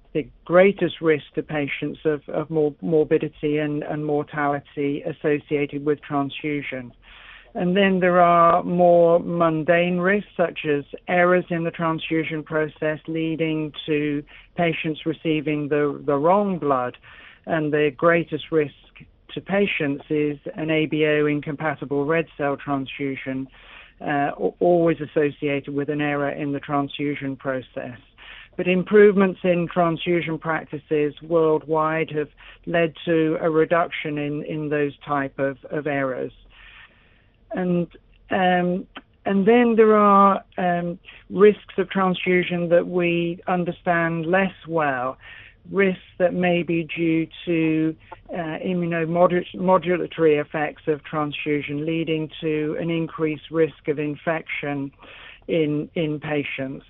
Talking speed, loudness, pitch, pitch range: 120 wpm, -22 LUFS, 155 Hz, 145-175 Hz